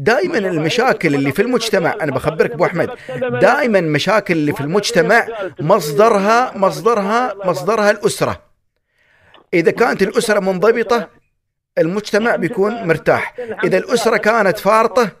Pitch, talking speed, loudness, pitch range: 210 Hz, 115 wpm, -15 LUFS, 180-230 Hz